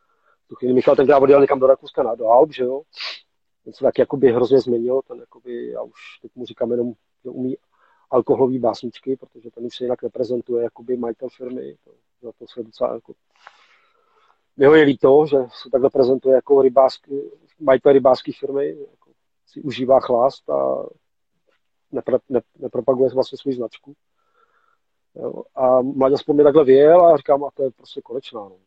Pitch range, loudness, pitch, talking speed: 125-145 Hz, -18 LUFS, 135 Hz, 170 wpm